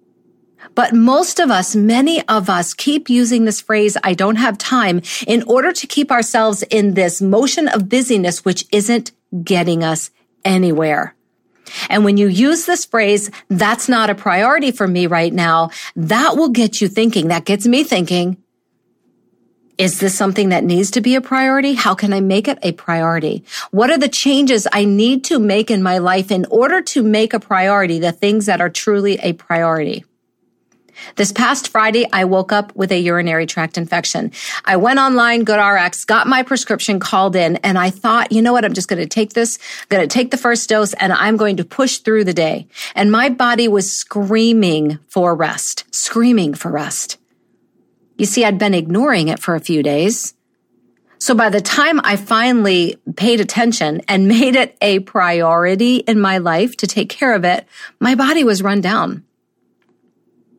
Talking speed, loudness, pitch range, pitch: 185 wpm, -14 LUFS, 185-240 Hz, 210 Hz